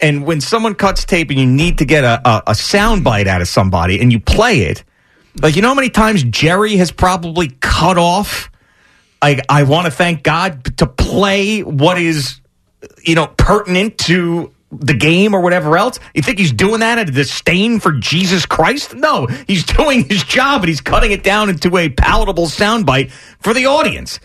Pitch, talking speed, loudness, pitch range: 170 Hz, 195 wpm, -12 LUFS, 145-200 Hz